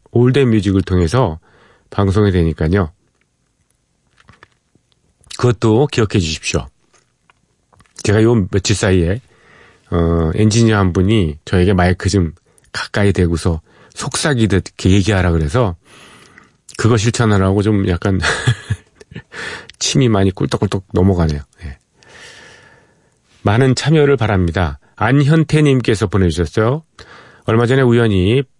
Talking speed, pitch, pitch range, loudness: 245 characters per minute, 100 Hz, 90-115 Hz, -15 LUFS